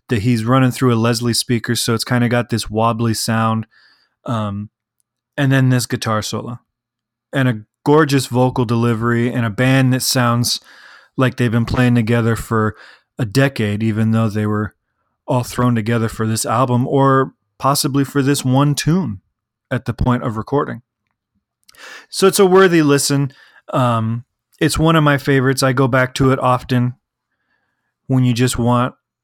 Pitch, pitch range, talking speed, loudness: 125 Hz, 115-135 Hz, 165 wpm, -16 LUFS